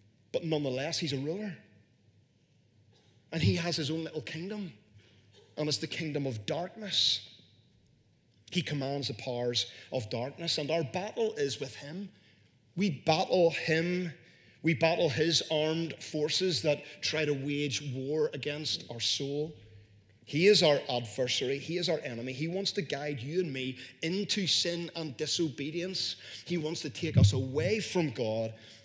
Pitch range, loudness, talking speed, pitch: 125-165 Hz, -31 LUFS, 150 wpm, 150 Hz